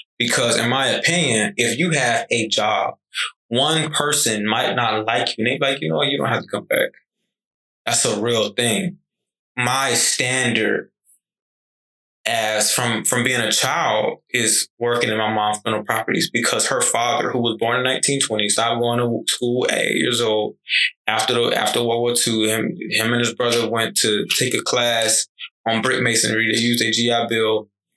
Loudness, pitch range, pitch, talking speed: -18 LUFS, 110-125 Hz, 115 Hz, 185 wpm